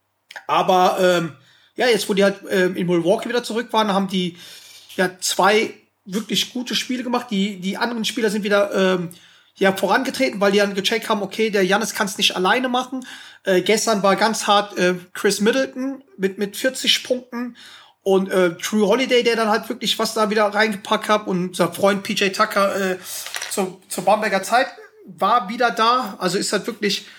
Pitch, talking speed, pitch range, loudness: 210 Hz, 190 wpm, 195-230 Hz, -19 LUFS